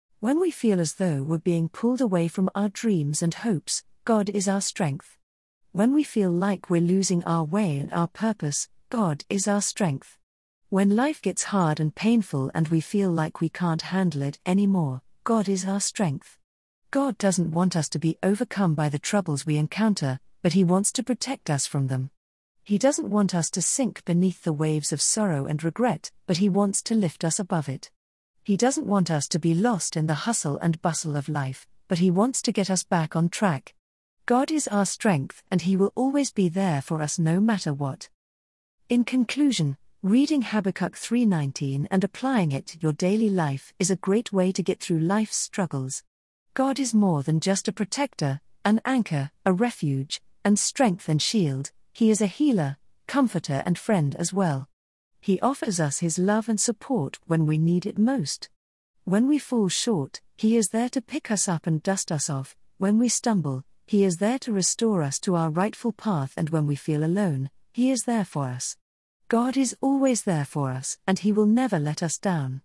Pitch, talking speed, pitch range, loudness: 190 Hz, 195 wpm, 155-215 Hz, -25 LUFS